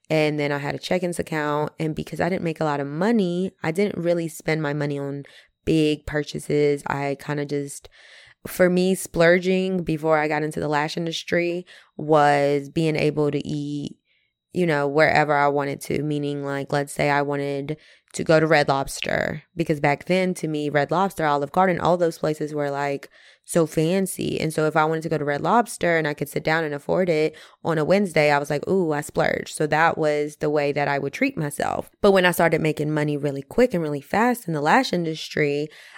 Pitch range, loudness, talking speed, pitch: 145-170 Hz, -22 LUFS, 215 wpm, 155 Hz